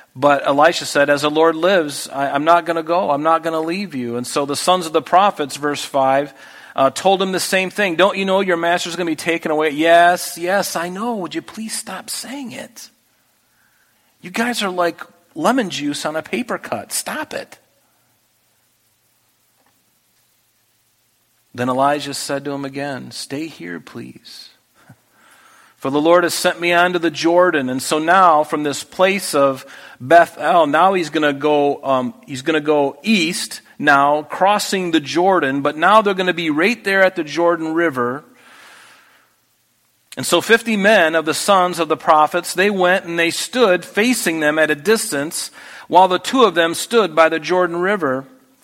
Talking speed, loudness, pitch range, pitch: 180 wpm, -16 LUFS, 145-185 Hz, 170 Hz